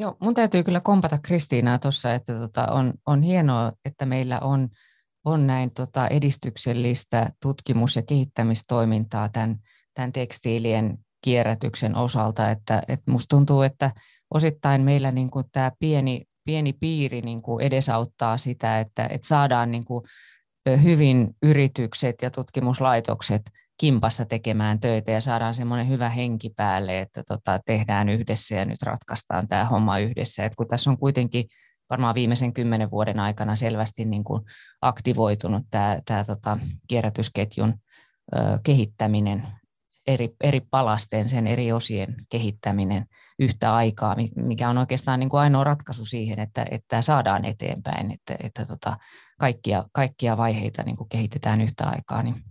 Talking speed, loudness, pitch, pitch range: 135 wpm, -24 LUFS, 120 Hz, 110-135 Hz